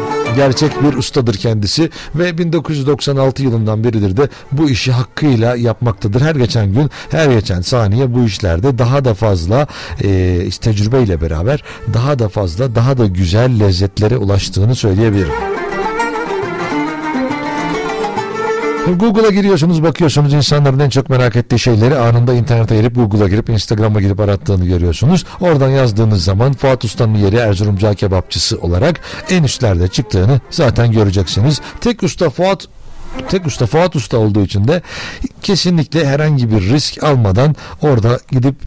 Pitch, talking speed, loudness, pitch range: 125 Hz, 135 wpm, -13 LUFS, 110-145 Hz